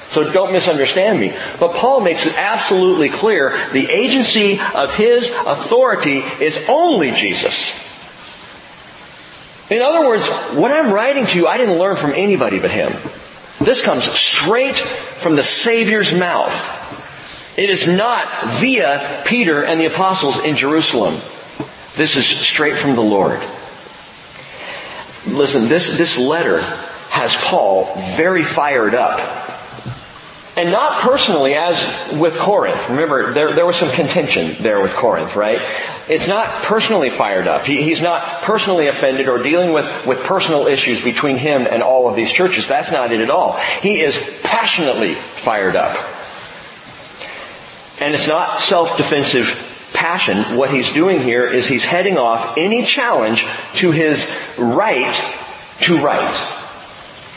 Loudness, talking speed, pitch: -14 LUFS, 140 wpm, 175 Hz